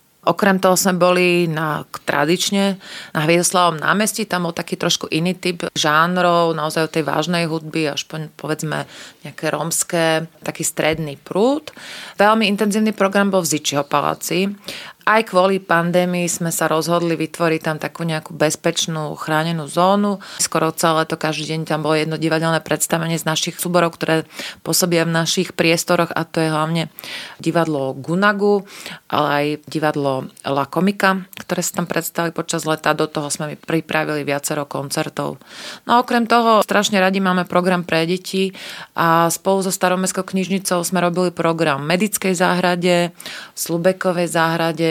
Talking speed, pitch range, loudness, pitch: 150 wpm, 155-185 Hz, -18 LUFS, 170 Hz